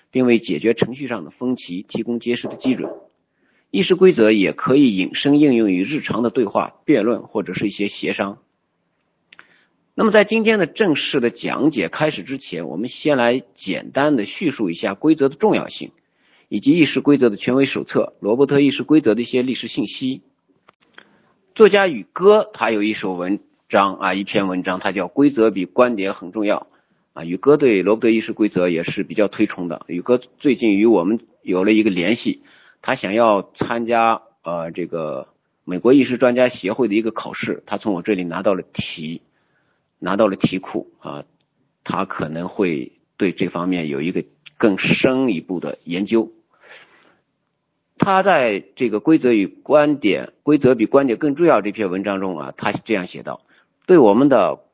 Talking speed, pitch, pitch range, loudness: 265 characters per minute, 120 Hz, 100-150 Hz, -18 LUFS